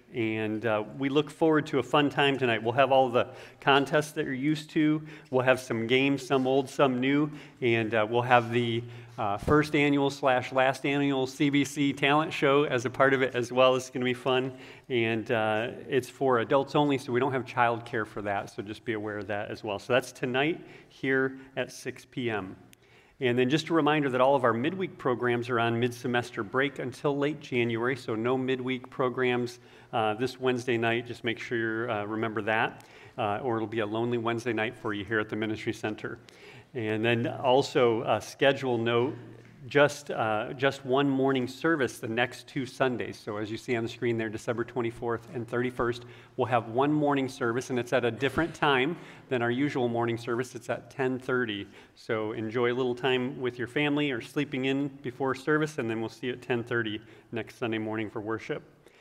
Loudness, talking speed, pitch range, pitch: -28 LUFS, 205 wpm, 115-135 Hz, 125 Hz